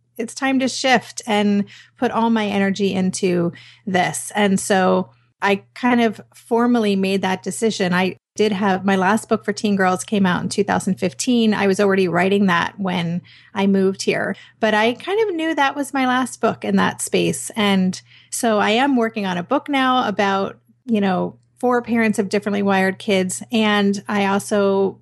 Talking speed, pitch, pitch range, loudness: 180 wpm, 205 Hz, 190-225 Hz, -19 LUFS